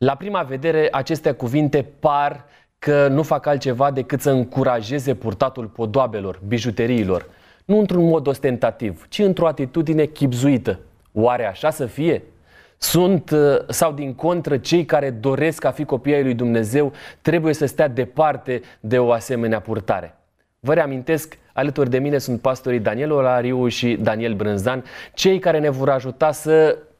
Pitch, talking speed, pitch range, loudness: 140 Hz, 150 wpm, 125-155 Hz, -20 LUFS